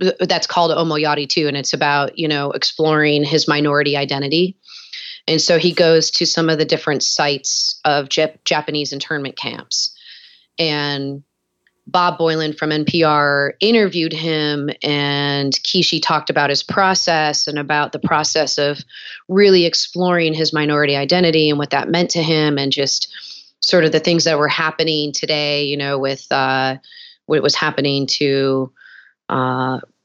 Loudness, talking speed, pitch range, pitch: -16 LUFS, 150 wpm, 145-165 Hz, 150 Hz